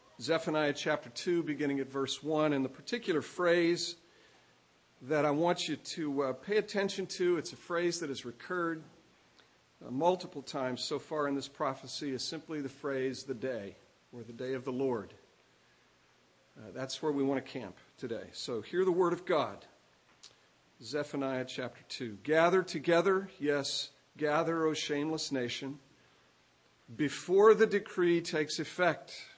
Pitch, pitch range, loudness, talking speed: 150 Hz, 135-170 Hz, -33 LUFS, 155 wpm